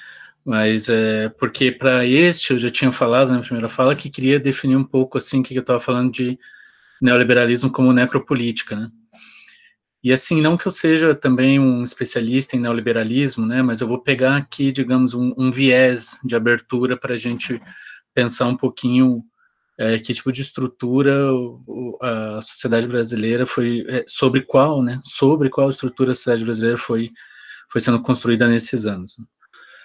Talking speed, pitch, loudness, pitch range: 165 wpm, 125 Hz, -18 LUFS, 120-130 Hz